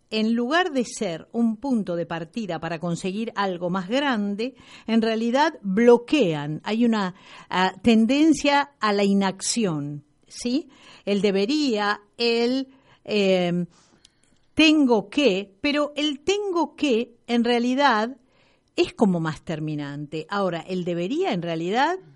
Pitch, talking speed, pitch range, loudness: 225 Hz, 120 wpm, 185-265 Hz, -23 LUFS